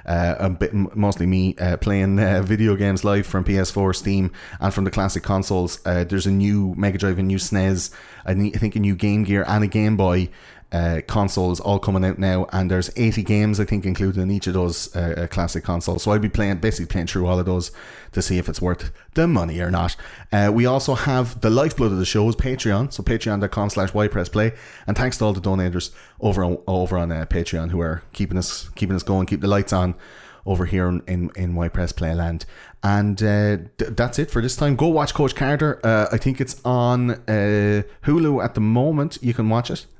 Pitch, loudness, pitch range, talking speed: 100 Hz, -21 LUFS, 90-110 Hz, 230 wpm